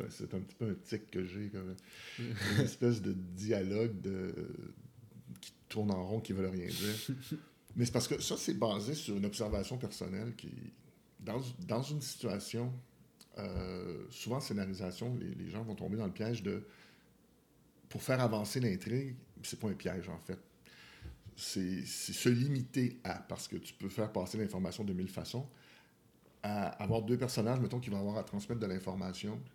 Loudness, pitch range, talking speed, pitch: -38 LUFS, 95-120 Hz, 180 wpm, 105 Hz